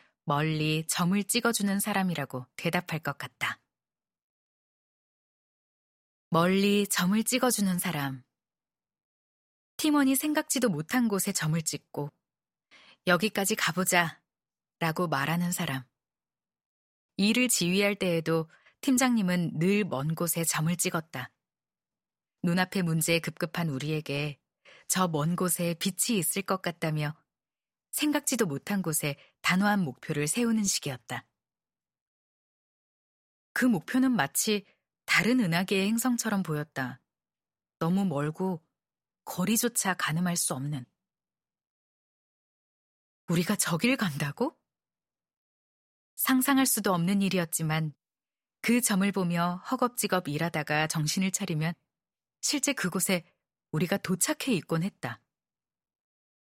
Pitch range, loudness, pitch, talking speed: 160-205 Hz, -28 LUFS, 180 Hz, 225 characters per minute